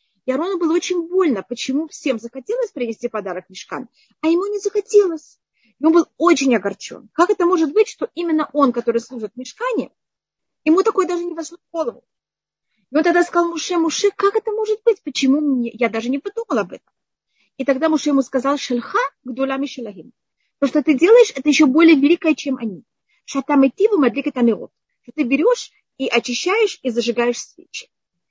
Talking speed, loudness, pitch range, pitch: 180 wpm, -18 LUFS, 255-355 Hz, 300 Hz